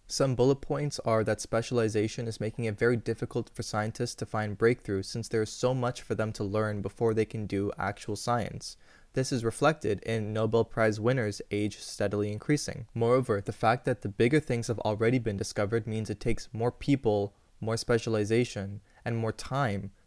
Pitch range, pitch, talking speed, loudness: 105-120 Hz, 115 Hz, 185 wpm, -30 LUFS